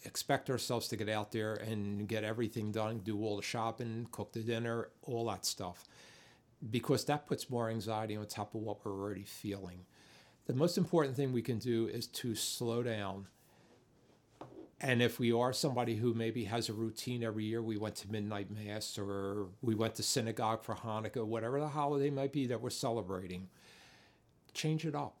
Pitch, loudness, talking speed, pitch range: 115 Hz, -37 LUFS, 185 wpm, 105-125 Hz